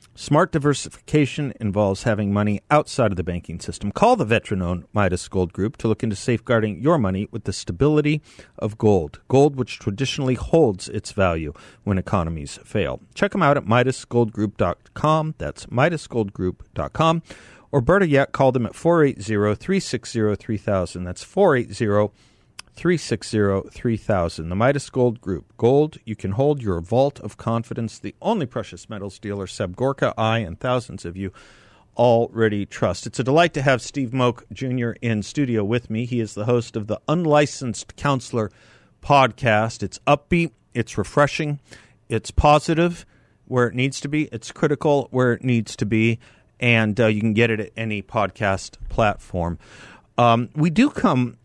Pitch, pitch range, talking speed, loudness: 115 Hz, 105-135 Hz, 160 wpm, -21 LUFS